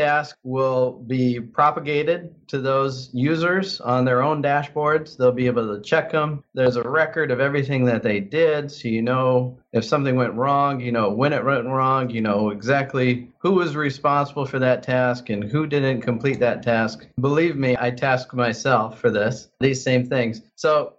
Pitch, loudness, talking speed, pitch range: 130 Hz, -21 LUFS, 185 wpm, 125-150 Hz